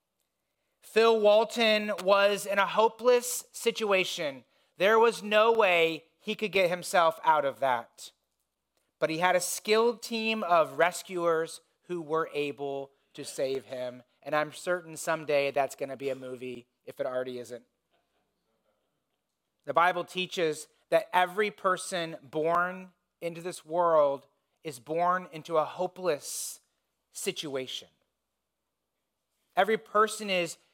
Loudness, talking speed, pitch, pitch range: -28 LUFS, 125 wpm, 175 Hz, 145-195 Hz